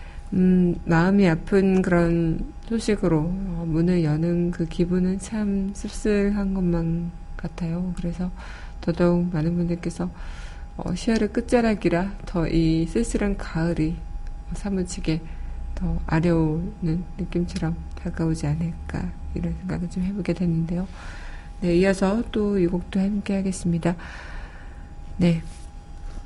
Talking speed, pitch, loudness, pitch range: 240 characters per minute, 175 Hz, -24 LUFS, 160-190 Hz